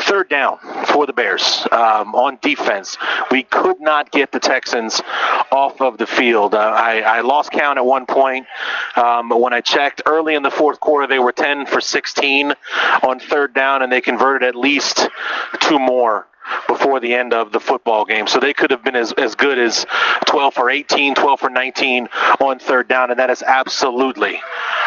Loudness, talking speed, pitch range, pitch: -15 LUFS, 195 wpm, 125-140 Hz, 130 Hz